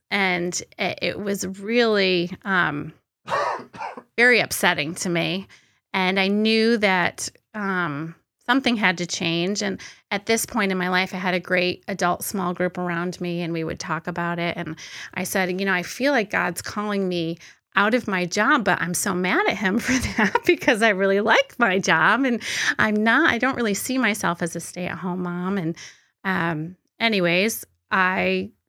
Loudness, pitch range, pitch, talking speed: -22 LUFS, 175-215 Hz, 185 Hz, 180 wpm